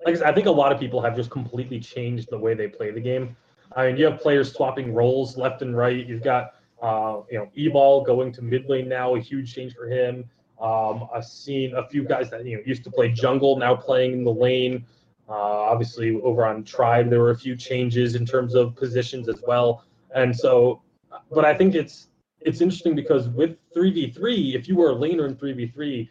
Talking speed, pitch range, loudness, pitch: 230 wpm, 120-135 Hz, -22 LUFS, 125 Hz